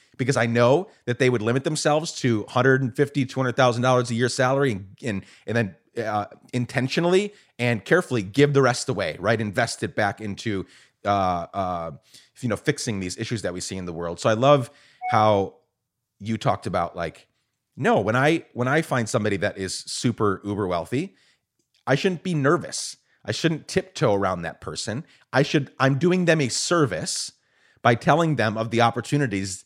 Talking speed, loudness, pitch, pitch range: 175 wpm, -23 LUFS, 120 Hz, 105-140 Hz